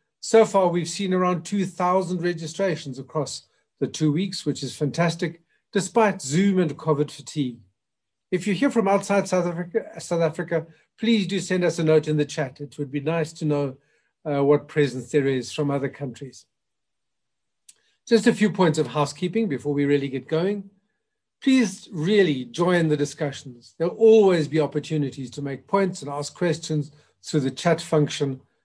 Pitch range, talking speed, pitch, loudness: 145-185 Hz, 170 wpm, 160 Hz, -23 LUFS